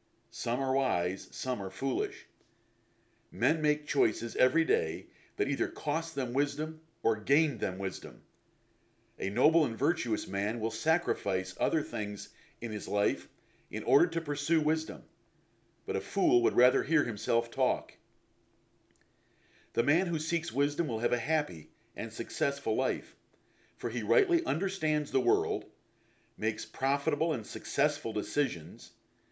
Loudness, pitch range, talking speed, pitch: -31 LUFS, 115-160 Hz, 140 wpm, 135 Hz